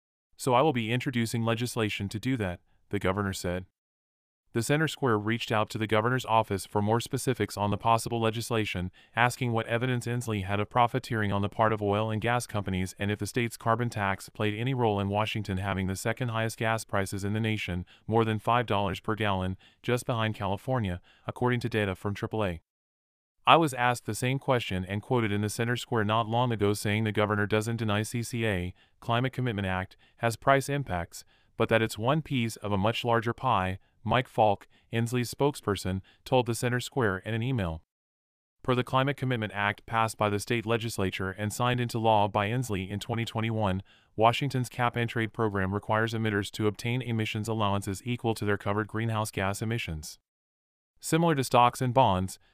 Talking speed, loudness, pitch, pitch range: 190 wpm, -29 LUFS, 110 Hz, 100-120 Hz